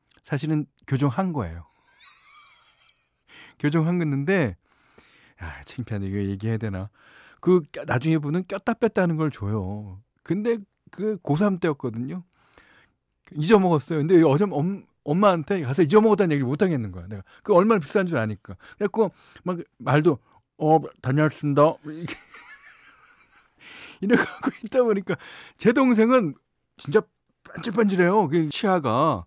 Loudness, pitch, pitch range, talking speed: -23 LUFS, 160 Hz, 135-195 Hz, 270 characters per minute